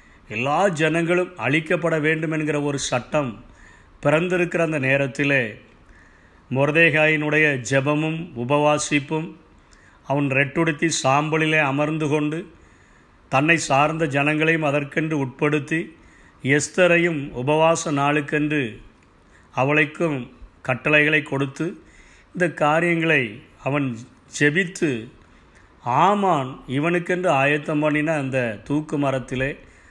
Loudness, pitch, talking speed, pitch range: -21 LUFS, 145 Hz, 80 wpm, 125-160 Hz